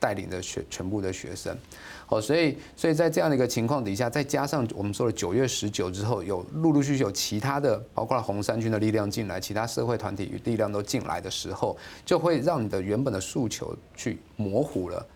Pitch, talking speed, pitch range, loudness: 115 Hz, 335 characters per minute, 100-140 Hz, -28 LUFS